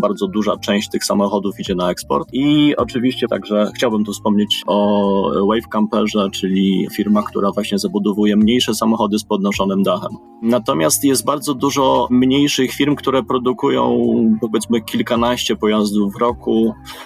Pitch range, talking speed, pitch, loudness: 105-125 Hz, 140 wpm, 110 Hz, -17 LUFS